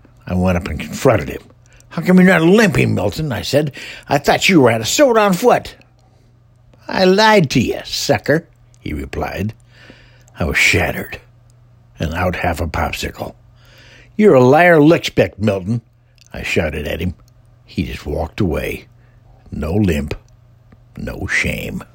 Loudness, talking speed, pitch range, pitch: -15 LUFS, 150 wpm, 100-125 Hz, 120 Hz